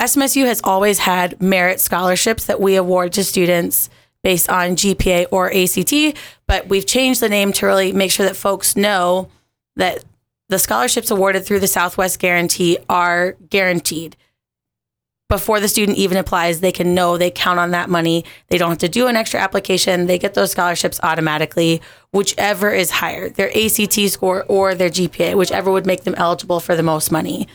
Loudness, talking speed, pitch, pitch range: -16 LUFS, 180 wpm, 185 Hz, 175-200 Hz